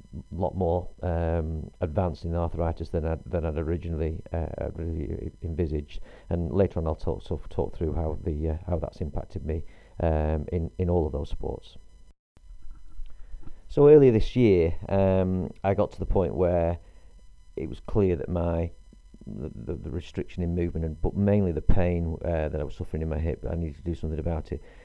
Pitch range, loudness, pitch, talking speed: 80-90 Hz, -27 LUFS, 85 Hz, 195 wpm